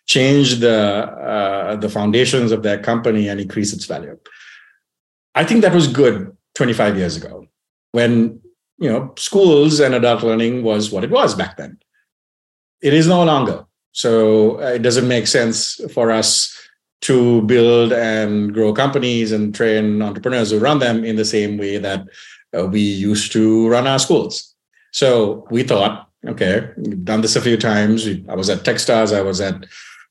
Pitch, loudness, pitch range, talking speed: 115 Hz, -16 LUFS, 105-125 Hz, 165 wpm